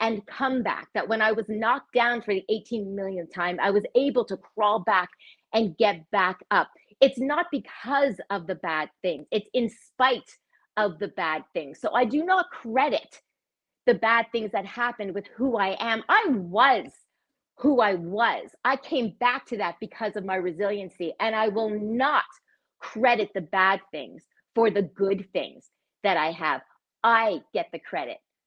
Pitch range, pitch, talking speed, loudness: 195-245 Hz, 220 Hz, 180 wpm, -25 LUFS